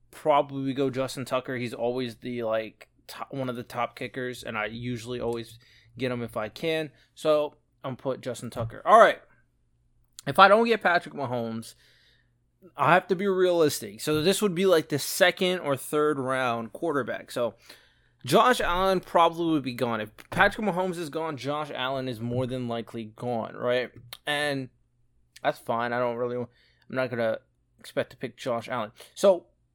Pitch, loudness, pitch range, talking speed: 130 Hz, -26 LUFS, 120-150 Hz, 180 wpm